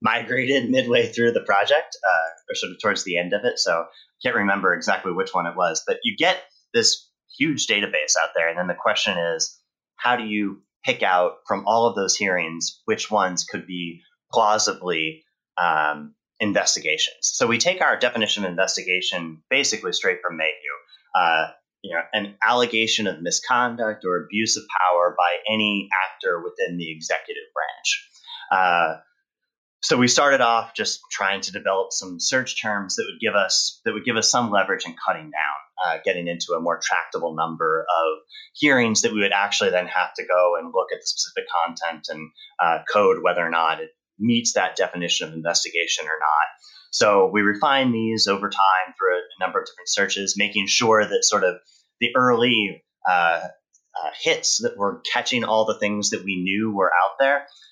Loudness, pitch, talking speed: -21 LUFS, 115 Hz, 185 wpm